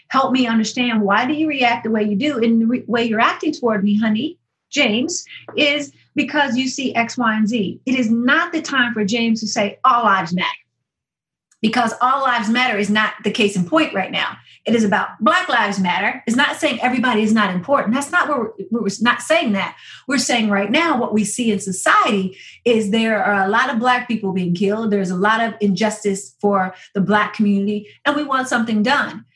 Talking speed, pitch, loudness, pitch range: 220 wpm, 230 Hz, -18 LUFS, 210-255 Hz